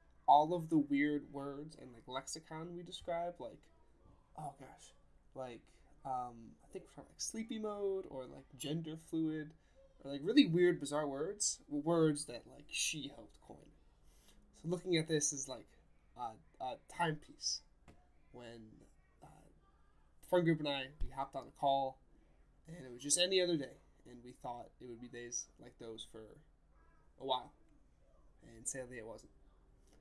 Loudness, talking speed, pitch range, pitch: -38 LUFS, 160 wpm, 125-165 Hz, 145 Hz